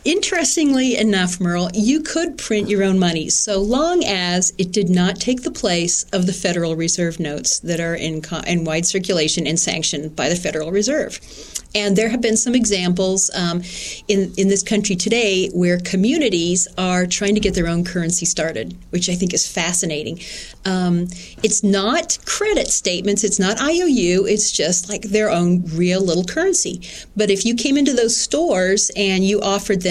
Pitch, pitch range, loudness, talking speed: 190 Hz, 175-215 Hz, -18 LUFS, 180 wpm